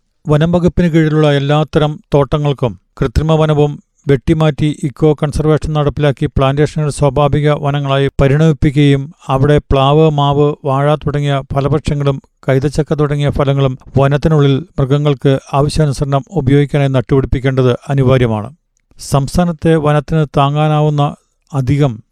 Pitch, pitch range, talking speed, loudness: 145 Hz, 140-155 Hz, 90 wpm, -13 LUFS